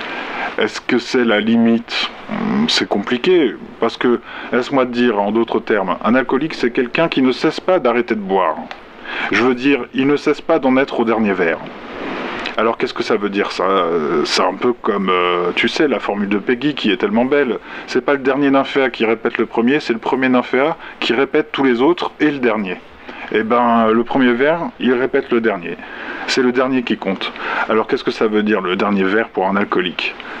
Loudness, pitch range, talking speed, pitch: -16 LUFS, 115-145 Hz, 210 wpm, 130 Hz